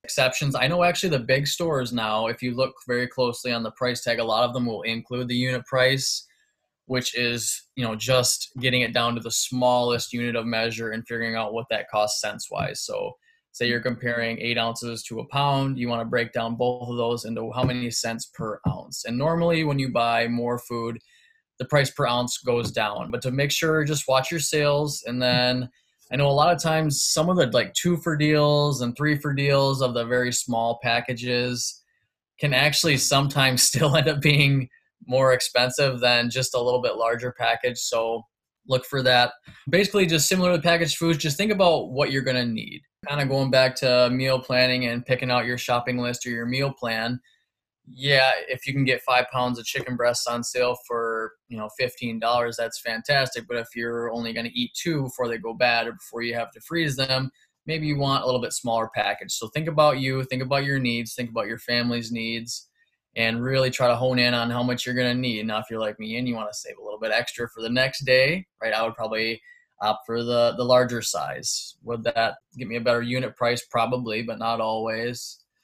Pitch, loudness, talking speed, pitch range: 125 Hz, -23 LUFS, 220 wpm, 120-135 Hz